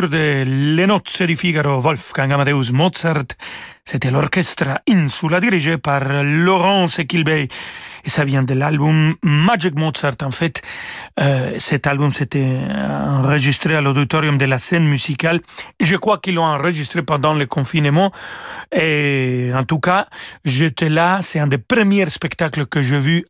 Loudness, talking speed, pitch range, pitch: -16 LUFS, 150 wpm, 140-175 Hz, 155 Hz